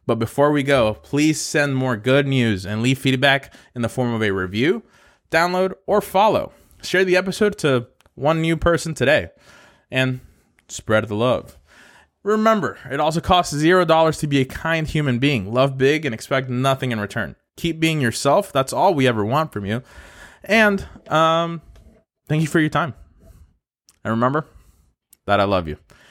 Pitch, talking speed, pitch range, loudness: 135 Hz, 170 wpm, 115-160 Hz, -19 LUFS